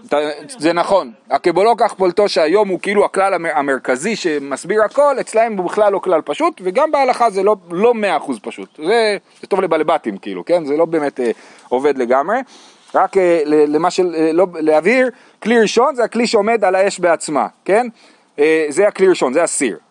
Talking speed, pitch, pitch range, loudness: 180 wpm, 190 Hz, 160-225 Hz, -15 LUFS